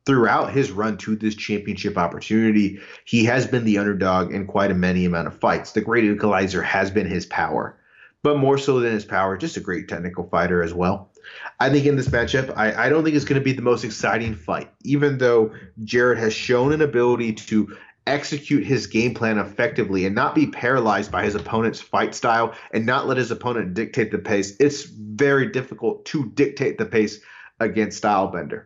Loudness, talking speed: -21 LUFS, 200 wpm